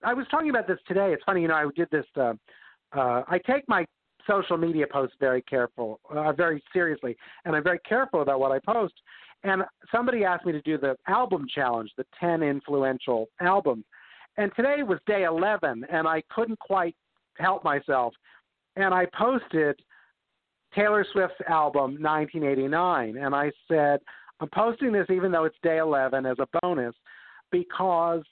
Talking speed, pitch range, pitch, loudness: 170 wpm, 145-195 Hz, 170 Hz, -26 LUFS